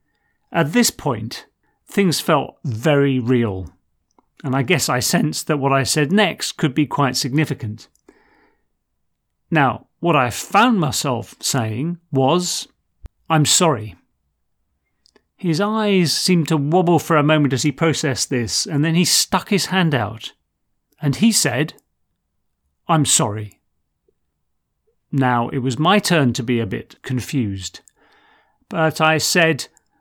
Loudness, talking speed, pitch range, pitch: -18 LUFS, 135 wpm, 115-170 Hz, 145 Hz